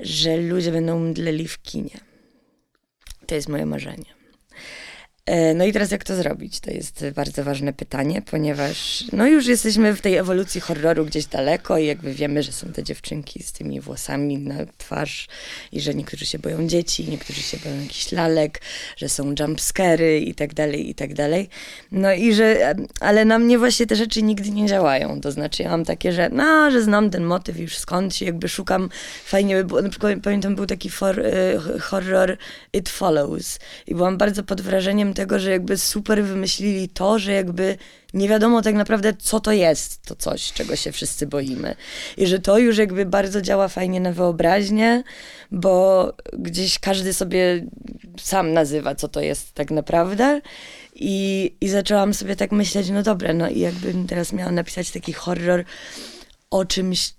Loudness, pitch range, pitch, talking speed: -21 LUFS, 160-205 Hz, 185 Hz, 175 wpm